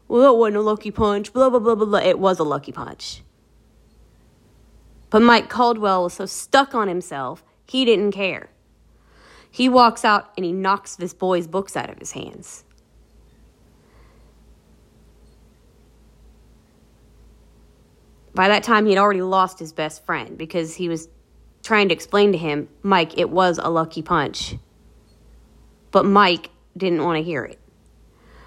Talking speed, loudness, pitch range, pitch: 150 wpm, -19 LUFS, 160-210 Hz, 185 Hz